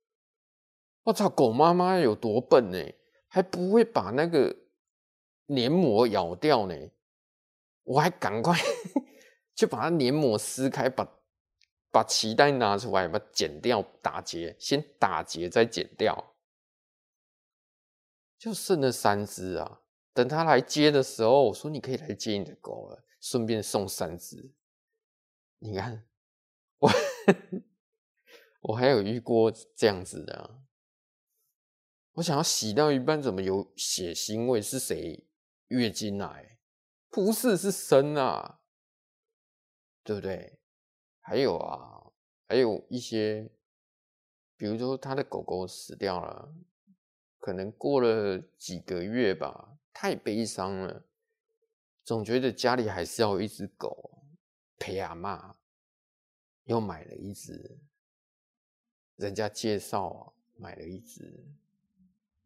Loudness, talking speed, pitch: -28 LUFS, 170 characters per minute, 125 Hz